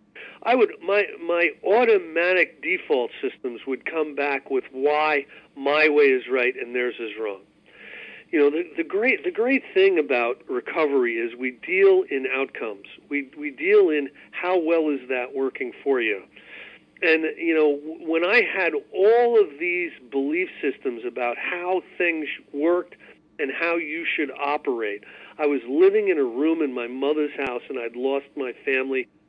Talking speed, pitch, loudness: 165 wpm, 185 Hz, -23 LUFS